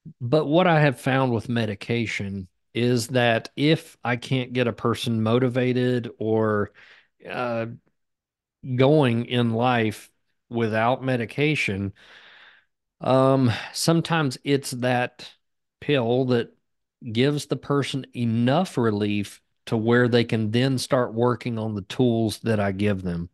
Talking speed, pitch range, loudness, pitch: 125 wpm, 115-130 Hz, -23 LUFS, 120 Hz